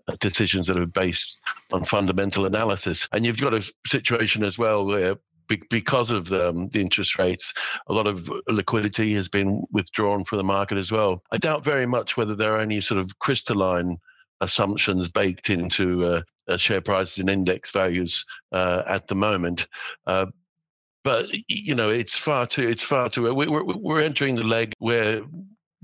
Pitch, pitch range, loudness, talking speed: 105 Hz, 95-115 Hz, -23 LUFS, 170 wpm